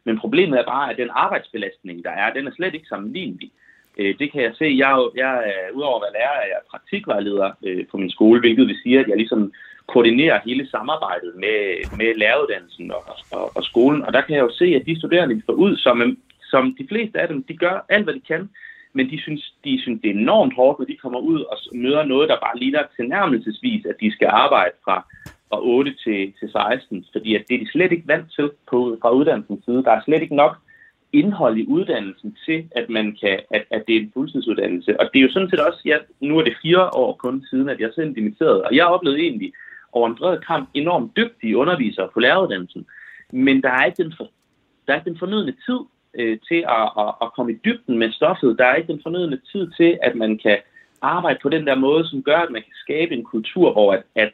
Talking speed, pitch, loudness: 235 wpm, 150 Hz, -19 LUFS